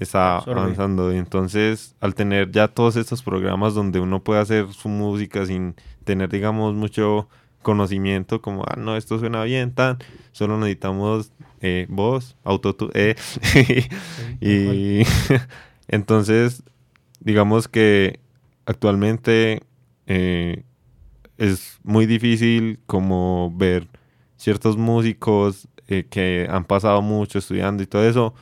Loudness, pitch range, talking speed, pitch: -20 LUFS, 95-115 Hz, 120 wpm, 105 Hz